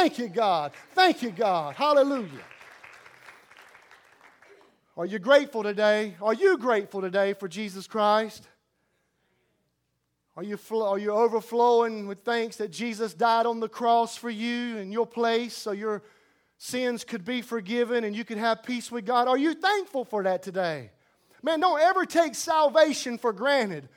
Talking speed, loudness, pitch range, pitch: 155 wpm, -26 LUFS, 215-250 Hz, 230 Hz